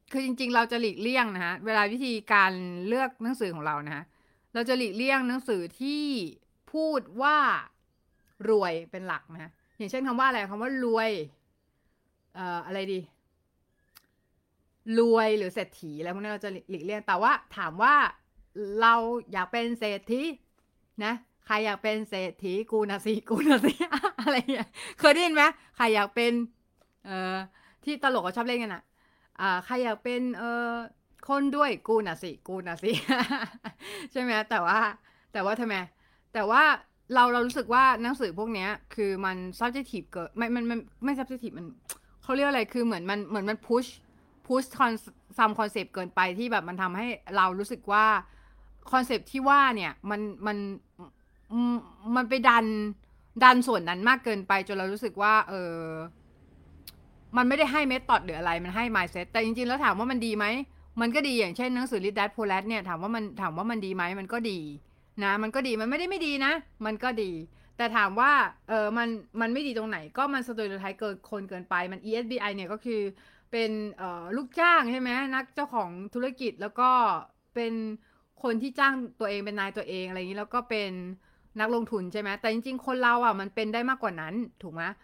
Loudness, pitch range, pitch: -28 LUFS, 195-250 Hz, 225 Hz